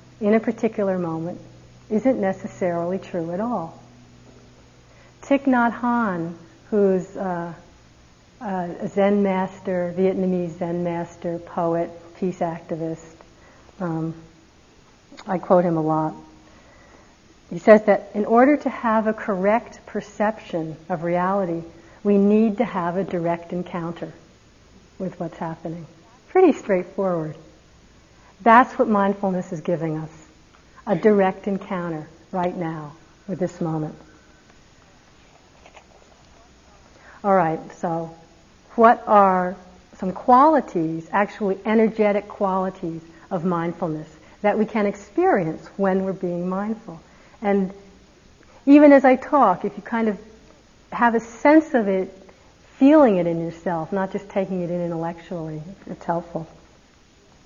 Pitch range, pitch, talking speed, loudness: 170-210 Hz, 185 Hz, 120 wpm, -21 LUFS